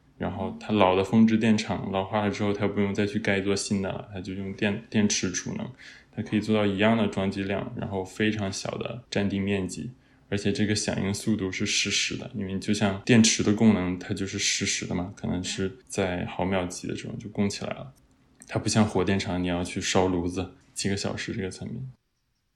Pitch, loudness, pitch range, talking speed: 100 Hz, -27 LUFS, 95-110 Hz, 310 characters per minute